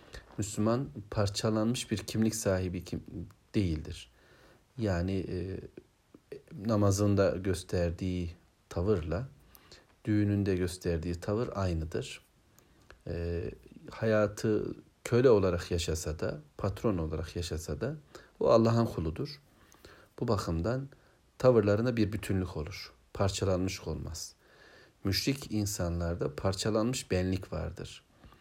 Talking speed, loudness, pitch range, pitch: 90 wpm, -32 LUFS, 90-110 Hz, 100 Hz